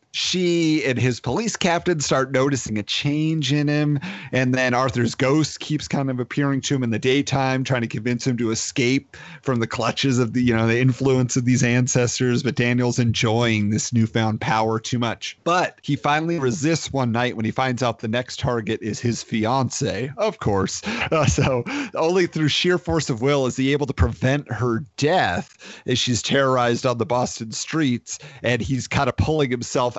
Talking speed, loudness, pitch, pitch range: 190 wpm, -21 LUFS, 130 Hz, 120-145 Hz